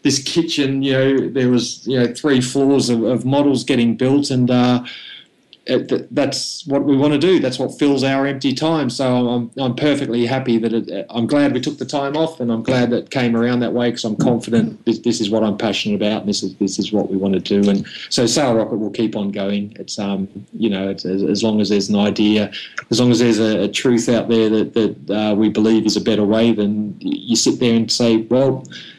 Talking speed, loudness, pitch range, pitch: 245 wpm, -17 LUFS, 105-135 Hz, 120 Hz